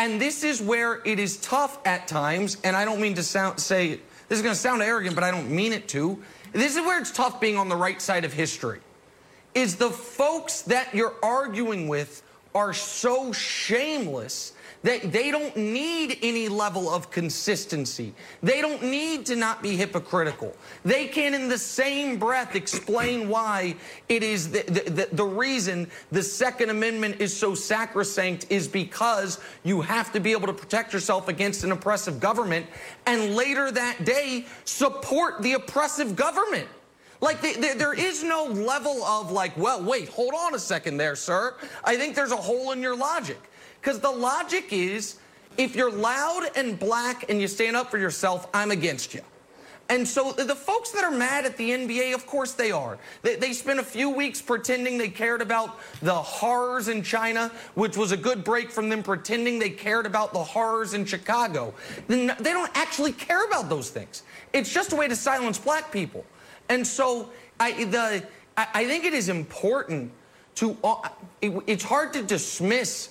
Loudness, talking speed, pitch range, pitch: -26 LUFS, 185 wpm, 195-260 Hz, 230 Hz